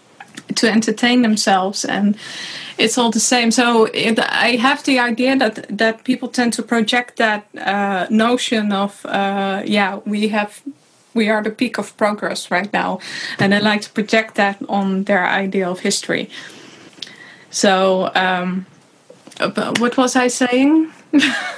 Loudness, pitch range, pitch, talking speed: -17 LUFS, 200-245 Hz, 220 Hz, 150 wpm